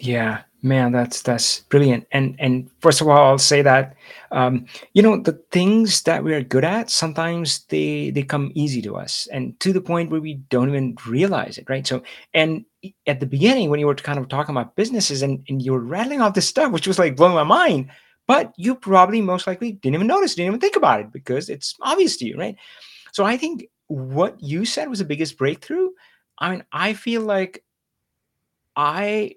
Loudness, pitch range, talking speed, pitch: -19 LUFS, 135-200 Hz, 210 wpm, 155 Hz